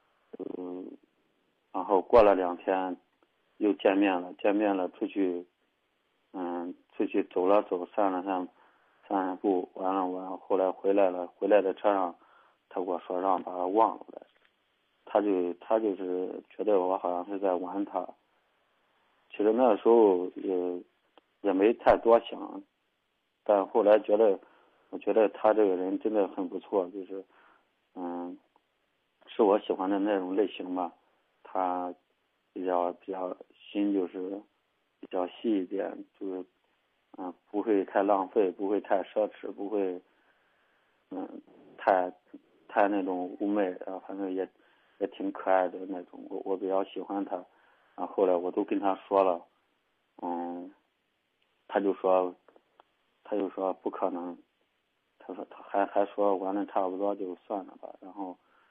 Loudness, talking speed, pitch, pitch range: -29 LUFS, 200 characters per minute, 95 Hz, 90-100 Hz